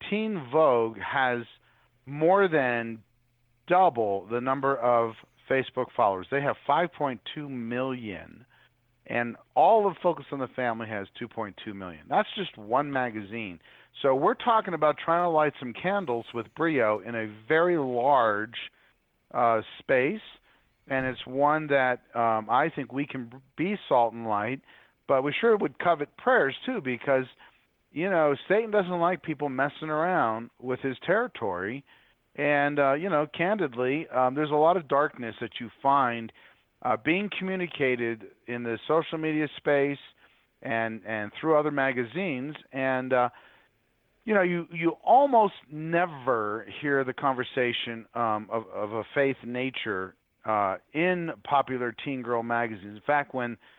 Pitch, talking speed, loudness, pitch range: 135 Hz, 145 wpm, -27 LUFS, 120-155 Hz